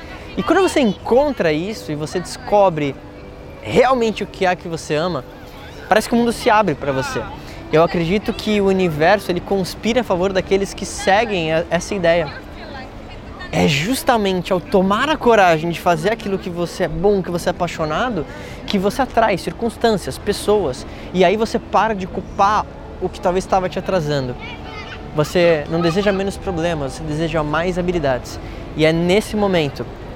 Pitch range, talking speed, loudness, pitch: 160-205 Hz, 170 wpm, -18 LUFS, 185 Hz